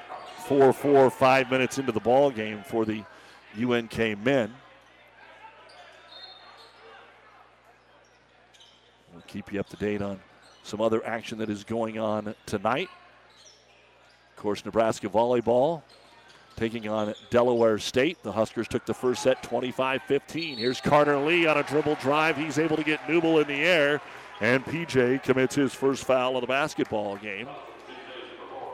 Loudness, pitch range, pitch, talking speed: -26 LUFS, 110-140 Hz, 125 Hz, 140 wpm